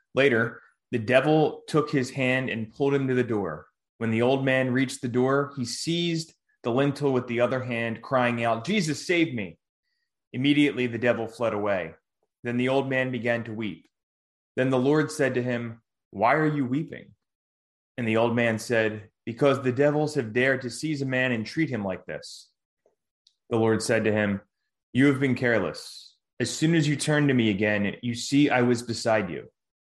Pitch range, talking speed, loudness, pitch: 115-140 Hz, 190 wpm, -25 LUFS, 125 Hz